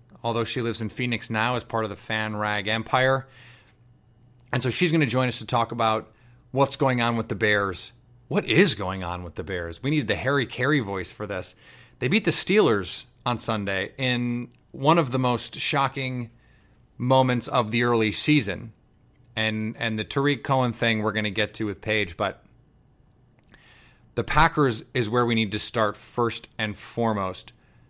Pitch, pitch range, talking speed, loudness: 120 Hz, 110-125 Hz, 185 wpm, -24 LUFS